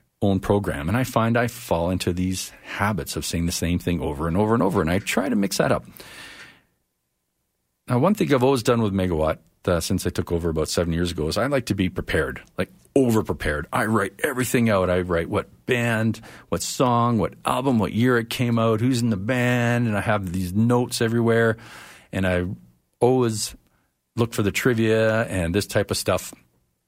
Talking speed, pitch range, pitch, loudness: 205 wpm, 85-120 Hz, 105 Hz, -23 LUFS